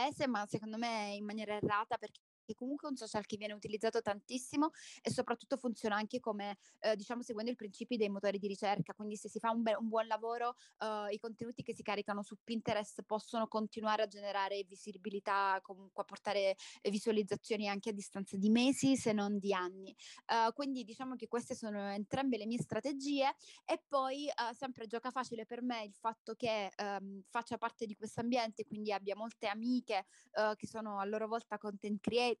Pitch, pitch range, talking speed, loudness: 220 Hz, 205-235 Hz, 190 wpm, -39 LUFS